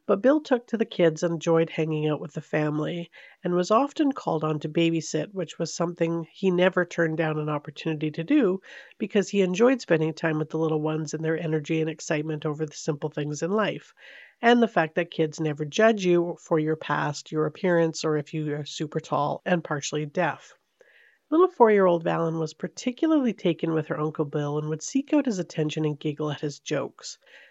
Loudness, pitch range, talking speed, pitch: -26 LUFS, 155-185 Hz, 210 wpm, 165 Hz